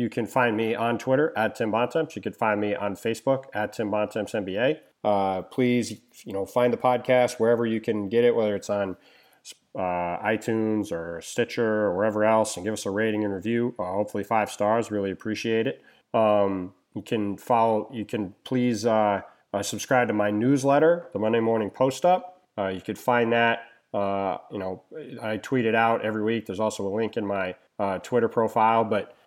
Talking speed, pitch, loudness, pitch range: 195 wpm, 110 Hz, -25 LUFS, 105-120 Hz